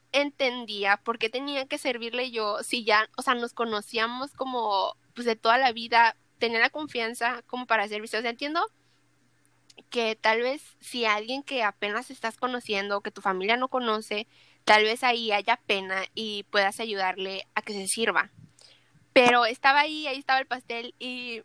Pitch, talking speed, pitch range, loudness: 230 Hz, 175 wpm, 215-250 Hz, -26 LUFS